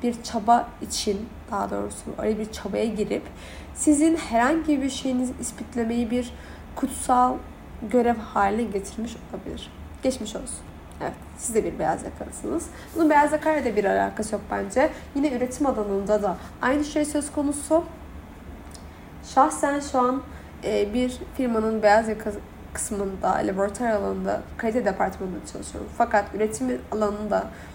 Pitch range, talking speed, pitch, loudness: 210-265 Hz, 130 wpm, 235 Hz, -25 LUFS